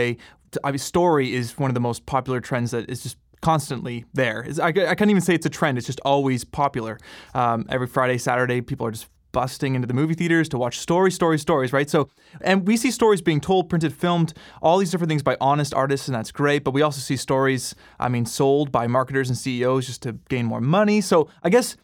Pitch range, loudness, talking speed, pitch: 125-165 Hz, -22 LUFS, 225 wpm, 135 Hz